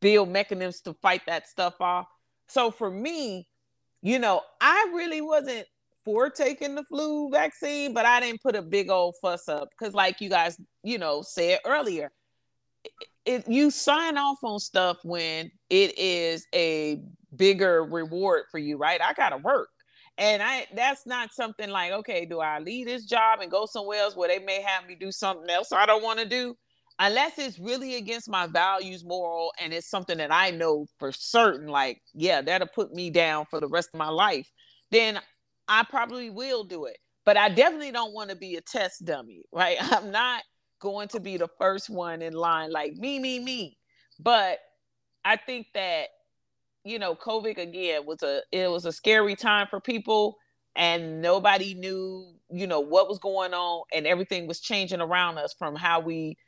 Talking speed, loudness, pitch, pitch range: 190 wpm, -26 LUFS, 195 Hz, 170-235 Hz